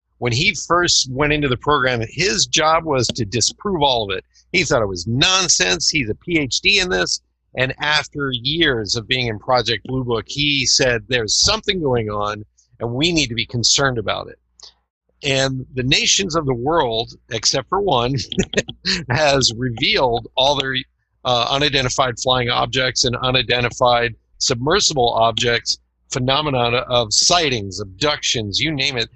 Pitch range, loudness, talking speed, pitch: 115-145 Hz, -17 LUFS, 155 wpm, 130 Hz